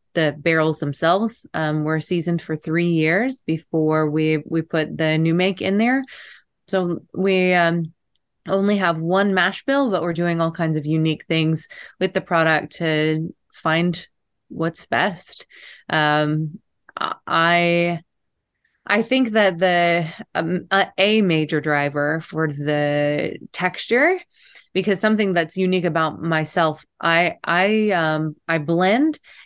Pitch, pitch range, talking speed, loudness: 170 Hz, 160-190 Hz, 130 wpm, -20 LUFS